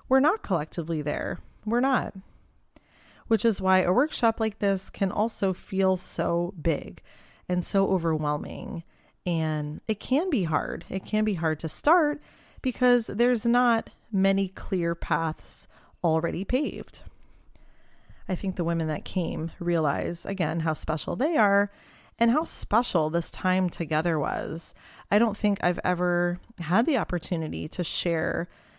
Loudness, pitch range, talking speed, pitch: -27 LUFS, 170-220 Hz, 145 wpm, 185 Hz